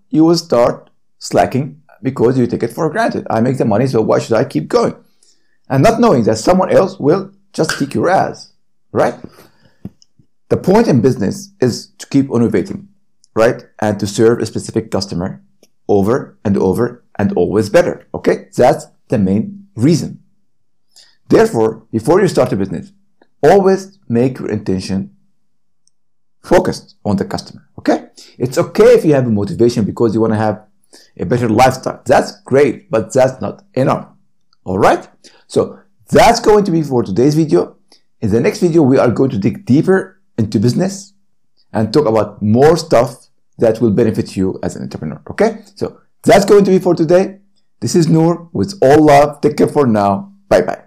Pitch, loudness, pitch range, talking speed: 130 Hz, -14 LUFS, 110-185 Hz, 175 wpm